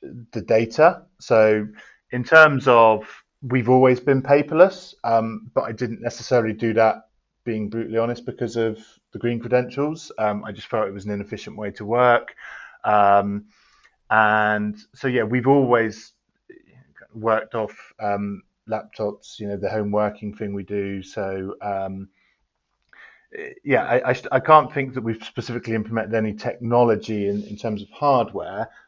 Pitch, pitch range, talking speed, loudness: 115 Hz, 105-125 Hz, 155 wpm, -21 LUFS